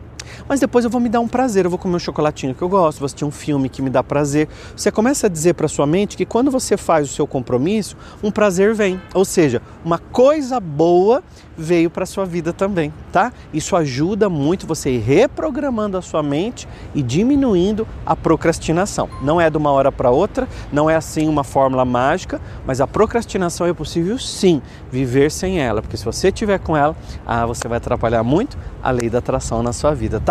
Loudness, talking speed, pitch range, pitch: -18 LUFS, 210 wpm, 135-195 Hz, 160 Hz